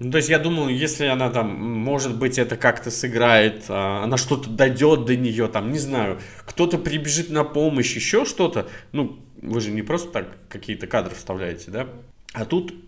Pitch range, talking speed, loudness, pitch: 115-150 Hz, 180 wpm, -22 LUFS, 125 Hz